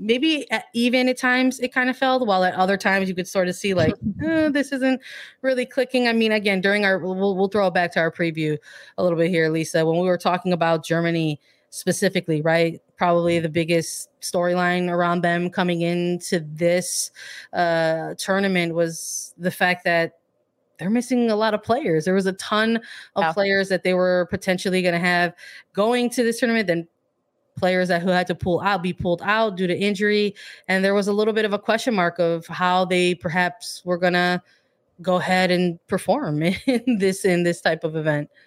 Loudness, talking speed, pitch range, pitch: -21 LUFS, 205 wpm, 175-210 Hz, 185 Hz